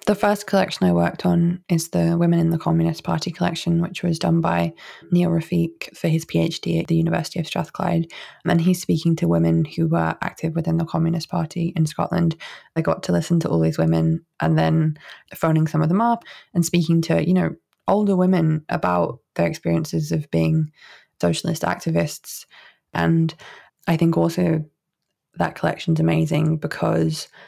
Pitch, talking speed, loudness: 165 Hz, 175 wpm, -21 LUFS